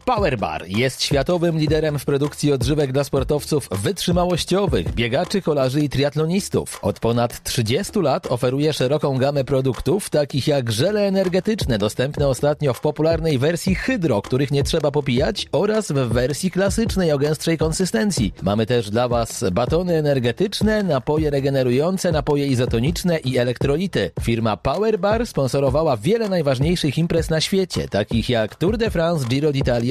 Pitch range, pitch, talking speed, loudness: 130-170 Hz, 145 Hz, 140 wpm, -20 LUFS